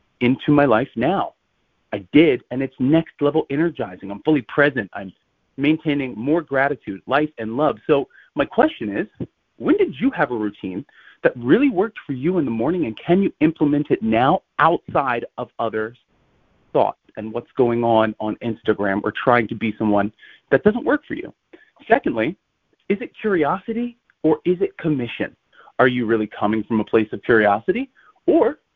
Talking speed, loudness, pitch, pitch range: 175 wpm, -20 LUFS, 140 Hz, 110-170 Hz